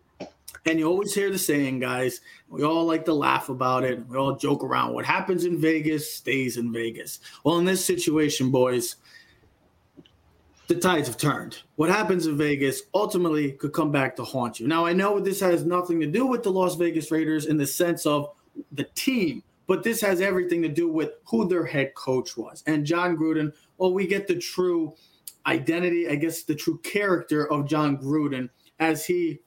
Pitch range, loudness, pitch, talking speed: 145-180 Hz, -25 LUFS, 160 Hz, 195 wpm